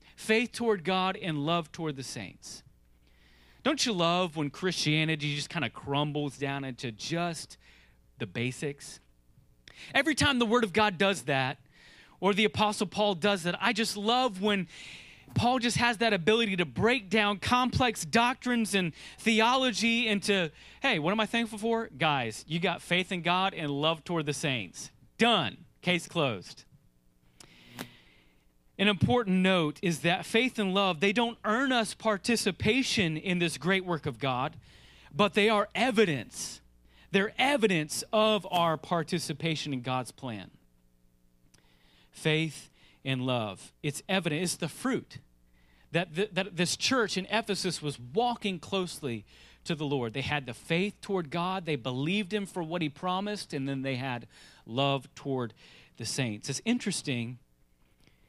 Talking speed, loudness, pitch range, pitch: 150 wpm, -29 LUFS, 135-205 Hz, 170 Hz